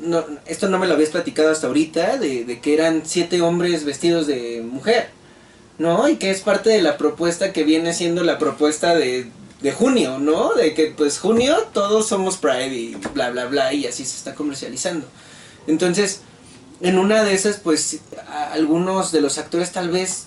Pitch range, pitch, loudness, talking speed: 150-190 Hz, 165 Hz, -19 LUFS, 190 wpm